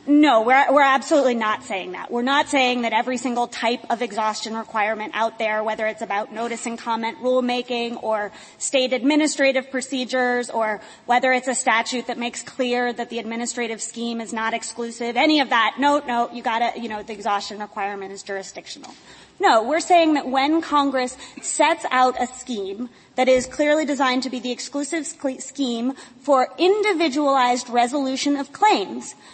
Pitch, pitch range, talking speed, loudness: 245 Hz, 225-275 Hz, 170 wpm, -21 LUFS